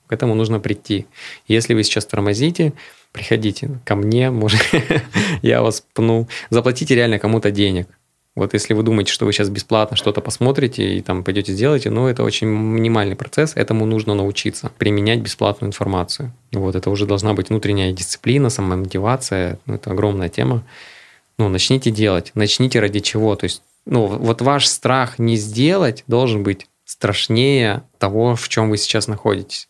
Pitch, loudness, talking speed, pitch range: 110 Hz, -18 LUFS, 160 wpm, 100-120 Hz